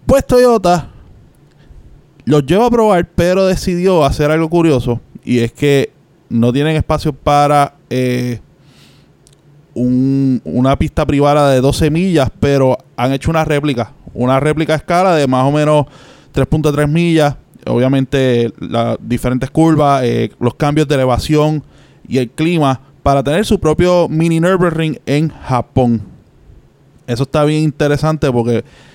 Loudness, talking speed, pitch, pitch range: -13 LUFS, 135 wpm, 145 Hz, 130-155 Hz